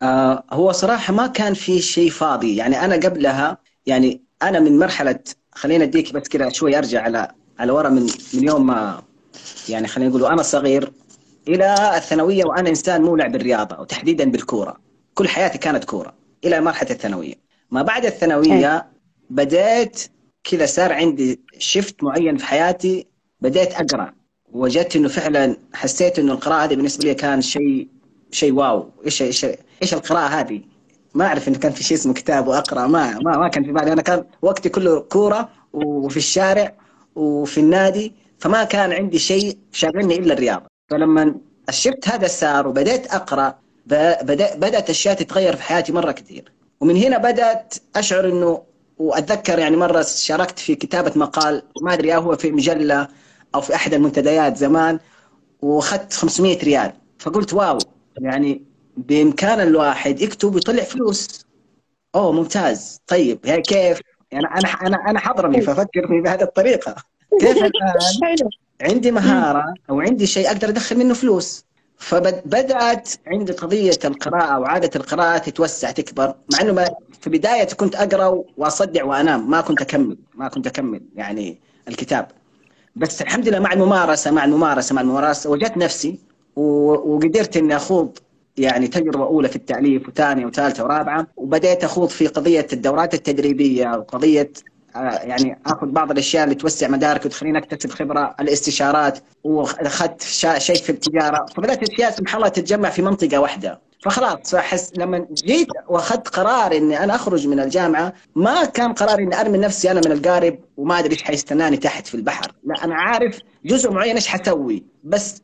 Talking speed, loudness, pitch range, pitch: 150 wpm, -18 LUFS, 150-210 Hz, 175 Hz